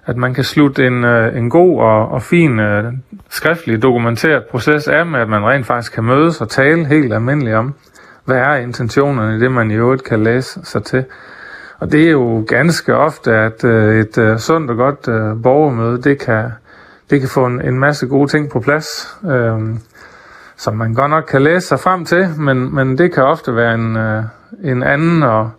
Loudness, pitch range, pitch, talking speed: -13 LUFS, 115-150 Hz, 130 Hz, 190 wpm